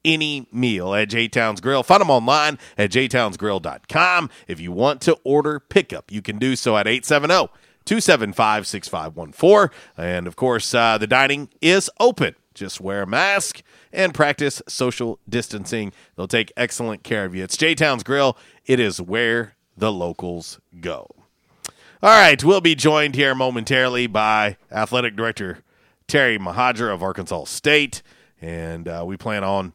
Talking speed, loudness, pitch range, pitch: 155 wpm, -18 LUFS, 105-140 Hz, 120 Hz